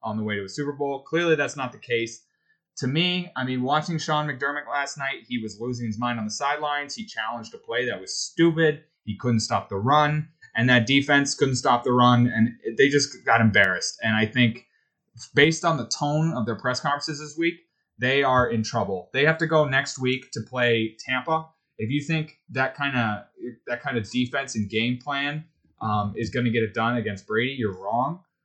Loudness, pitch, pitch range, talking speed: -24 LUFS, 130 Hz, 115-150 Hz, 215 wpm